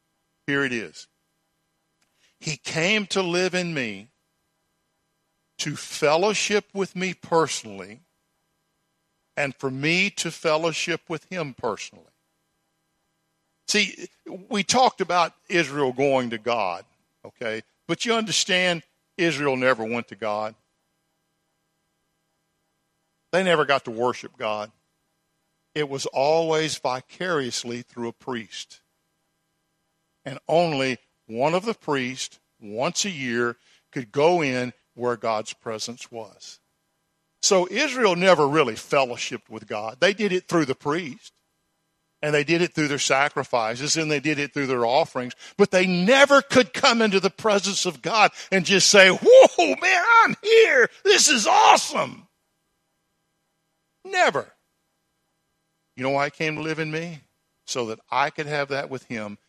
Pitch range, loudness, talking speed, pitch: 140-175 Hz, -22 LUFS, 135 wpm, 160 Hz